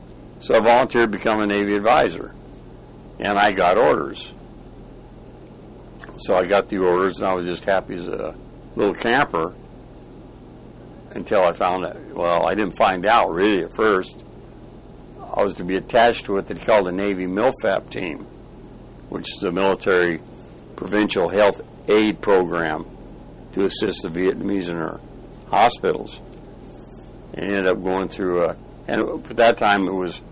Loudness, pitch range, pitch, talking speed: -20 LUFS, 90-105 Hz, 95 Hz, 155 wpm